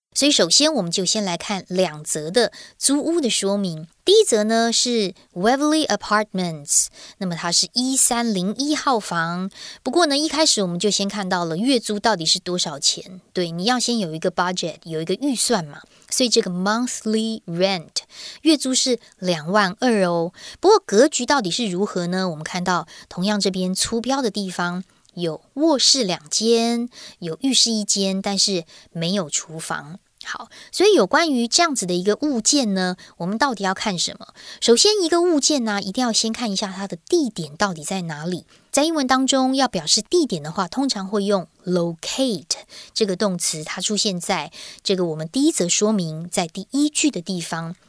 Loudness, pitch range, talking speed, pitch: -20 LUFS, 180-250 Hz, 305 characters per minute, 205 Hz